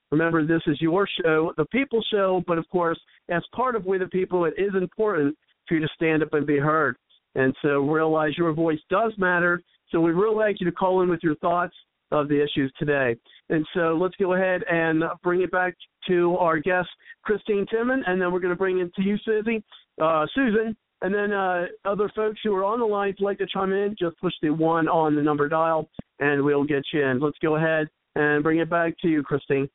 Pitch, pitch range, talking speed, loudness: 175 Hz, 155-195 Hz, 230 wpm, -24 LUFS